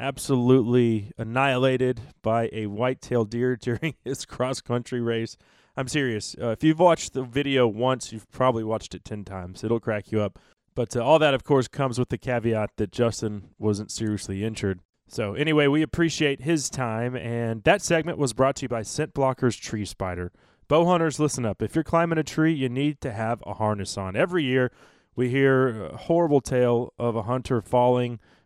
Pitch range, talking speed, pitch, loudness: 110-135 Hz, 190 wpm, 125 Hz, -25 LUFS